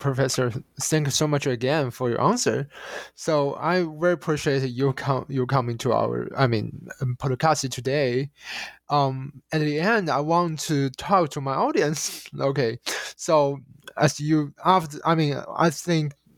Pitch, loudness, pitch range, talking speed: 145 Hz, -24 LUFS, 135-155 Hz, 160 wpm